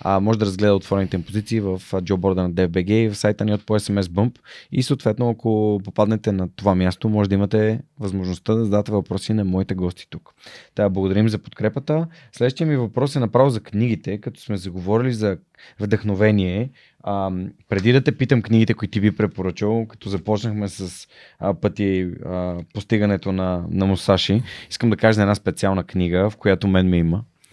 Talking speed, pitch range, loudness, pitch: 180 wpm, 95-110 Hz, -21 LUFS, 105 Hz